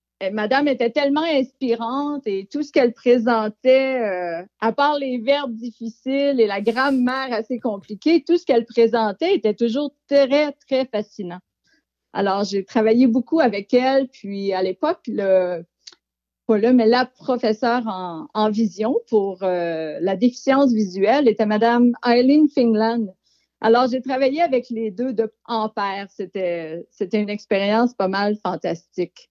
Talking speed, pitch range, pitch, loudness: 145 wpm, 200-260 Hz, 230 Hz, -20 LUFS